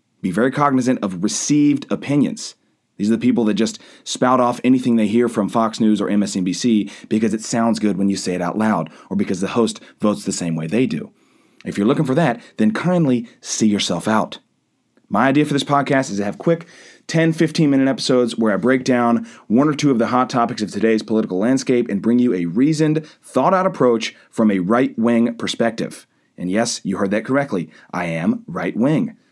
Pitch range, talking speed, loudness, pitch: 105-135 Hz, 210 wpm, -18 LUFS, 120 Hz